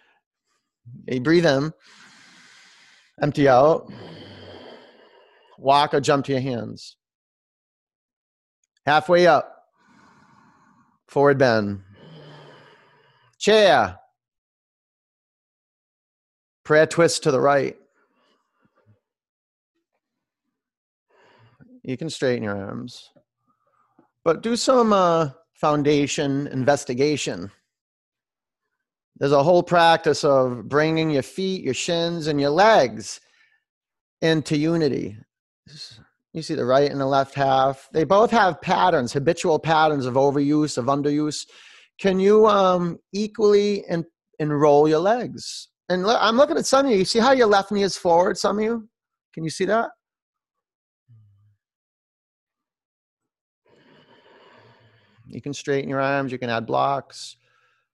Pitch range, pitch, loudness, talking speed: 135-190 Hz, 150 Hz, -20 LUFS, 110 wpm